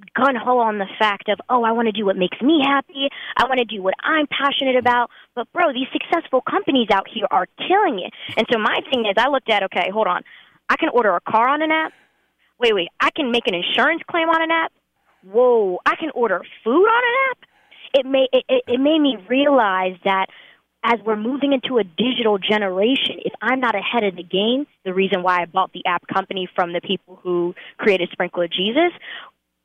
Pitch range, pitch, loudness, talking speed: 195-285 Hz, 240 Hz, -19 LUFS, 220 wpm